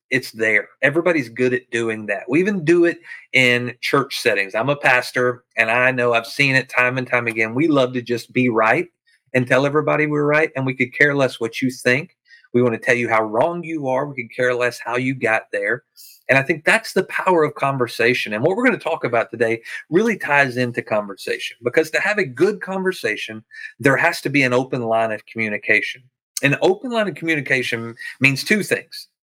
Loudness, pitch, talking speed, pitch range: -19 LUFS, 130 Hz, 220 wpm, 120-150 Hz